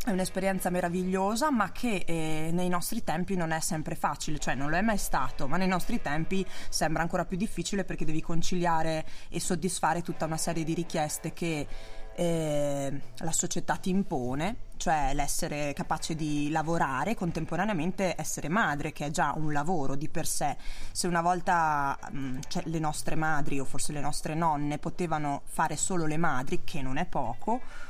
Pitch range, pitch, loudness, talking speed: 150-180 Hz, 165 Hz, -31 LUFS, 175 wpm